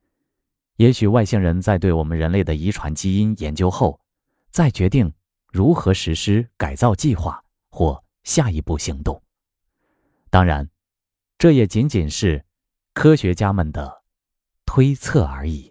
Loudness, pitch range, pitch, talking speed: -19 LUFS, 80-105 Hz, 95 Hz, 200 characters per minute